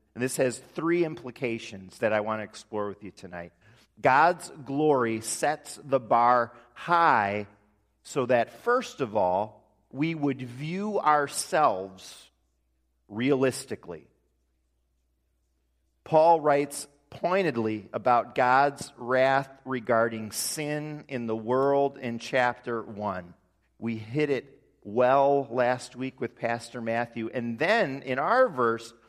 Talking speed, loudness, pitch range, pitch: 120 wpm, -27 LUFS, 105-140 Hz, 120 Hz